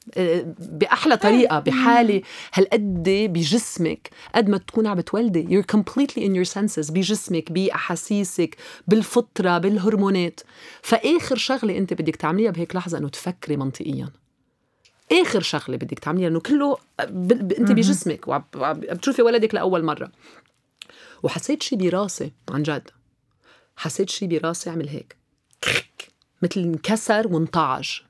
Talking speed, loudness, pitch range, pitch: 120 wpm, -22 LUFS, 165-220 Hz, 190 Hz